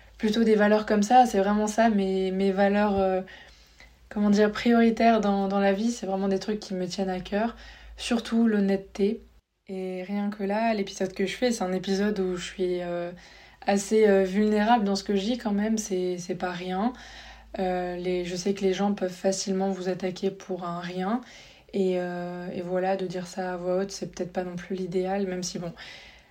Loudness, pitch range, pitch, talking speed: -26 LUFS, 185-210 Hz, 195 Hz, 210 wpm